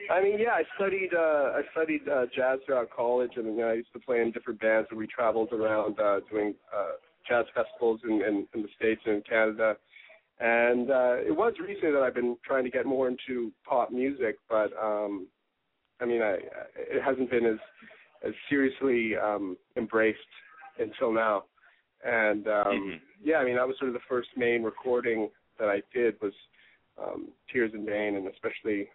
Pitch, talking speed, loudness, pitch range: 115 Hz, 190 wpm, -29 LUFS, 110-130 Hz